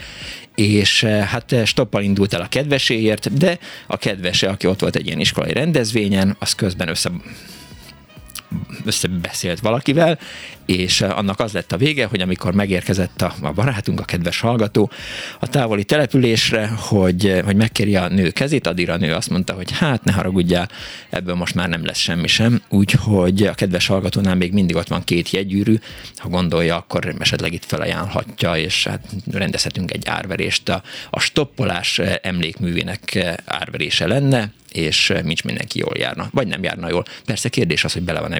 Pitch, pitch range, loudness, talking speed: 100 Hz, 90-115 Hz, -18 LUFS, 160 wpm